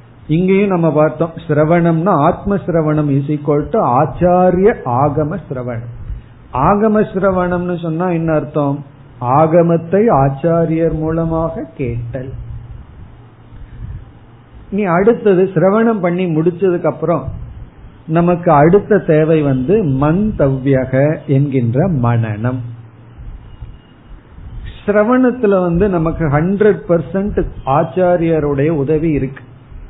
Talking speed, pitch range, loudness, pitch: 75 wpm, 140-180 Hz, -14 LUFS, 160 Hz